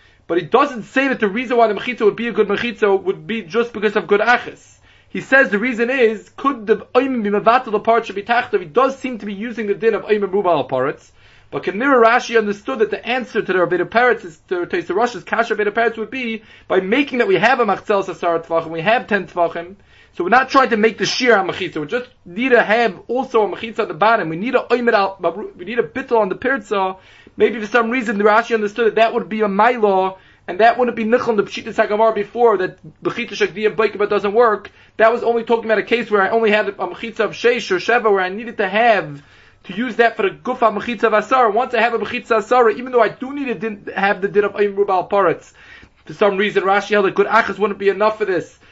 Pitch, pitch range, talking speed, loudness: 220 Hz, 200-235 Hz, 240 wpm, -17 LUFS